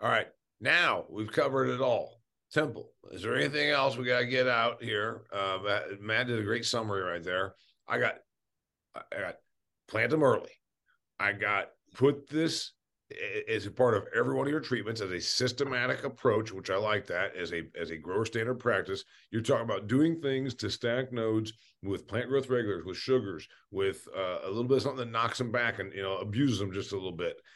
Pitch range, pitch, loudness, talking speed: 105-135 Hz, 120 Hz, -31 LUFS, 210 wpm